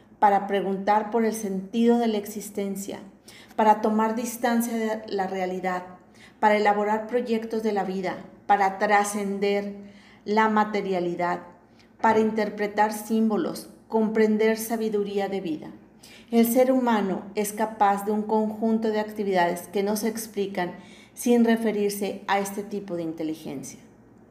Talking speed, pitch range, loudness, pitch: 130 wpm, 195-220 Hz, -25 LUFS, 210 Hz